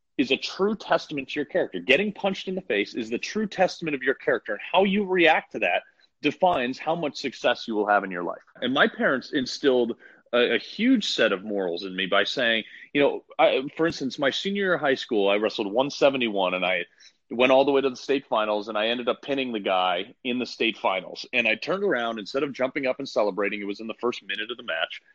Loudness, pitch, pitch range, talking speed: -25 LUFS, 130 Hz, 105-160 Hz, 250 wpm